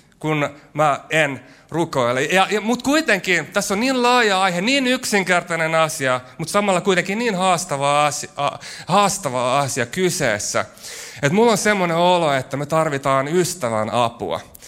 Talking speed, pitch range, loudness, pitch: 140 wpm, 145-200 Hz, -19 LUFS, 170 Hz